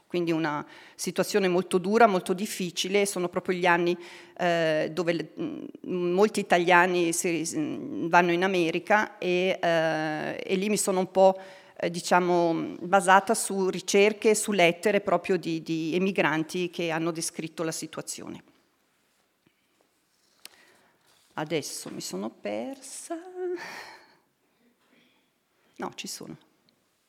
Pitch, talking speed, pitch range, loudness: 185 Hz, 115 wpm, 175-205 Hz, -26 LUFS